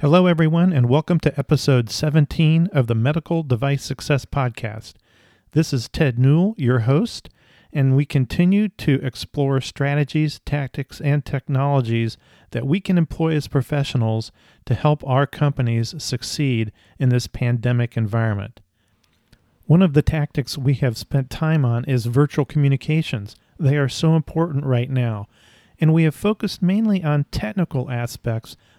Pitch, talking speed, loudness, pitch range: 140 Hz, 145 wpm, -20 LUFS, 120-155 Hz